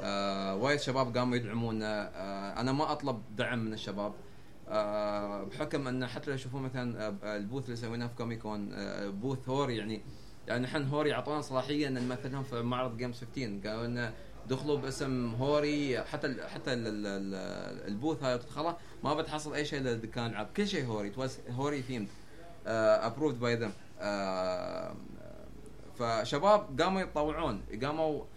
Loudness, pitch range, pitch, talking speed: -35 LUFS, 110-145 Hz, 125 Hz, 135 wpm